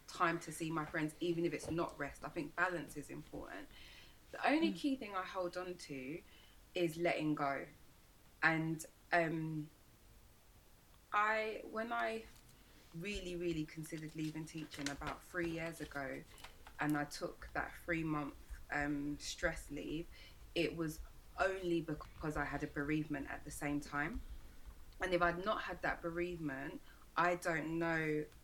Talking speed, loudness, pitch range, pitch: 150 wpm, -40 LUFS, 145-175 Hz, 160 Hz